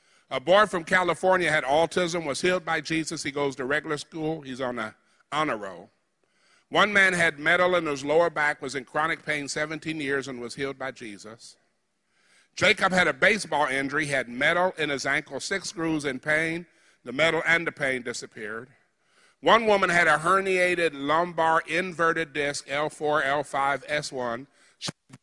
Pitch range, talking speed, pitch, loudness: 140-170 Hz, 170 wpm, 155 Hz, -25 LUFS